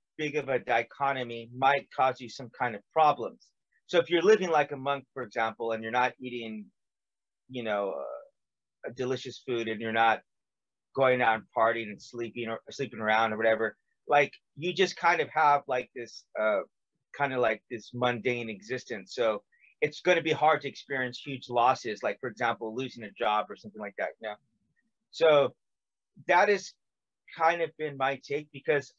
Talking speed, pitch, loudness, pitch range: 180 wpm, 125 Hz, -29 LUFS, 115-150 Hz